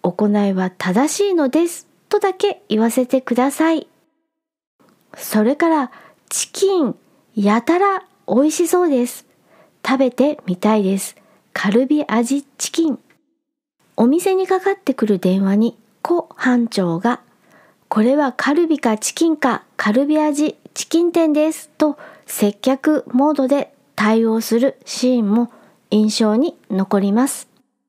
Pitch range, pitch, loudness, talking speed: 225-315 Hz, 265 Hz, -18 LUFS, 255 characters per minute